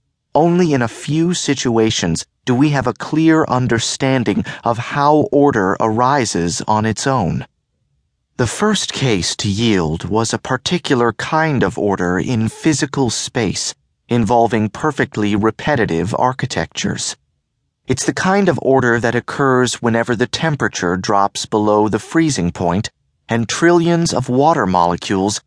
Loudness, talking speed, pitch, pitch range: -16 LUFS, 130 wpm, 120 Hz, 110-145 Hz